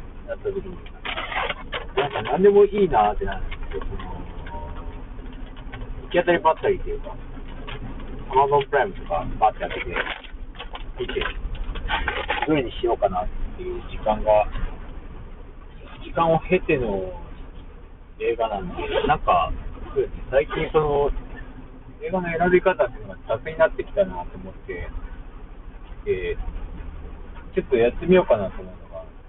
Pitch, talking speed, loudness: 145 Hz, 260 characters per minute, -23 LUFS